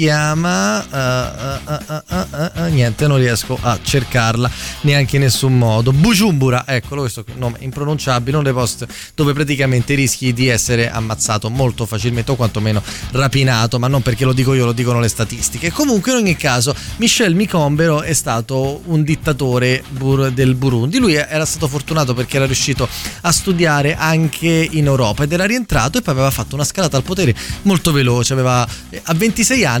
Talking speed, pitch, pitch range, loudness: 175 wpm, 135 Hz, 125-155 Hz, -15 LUFS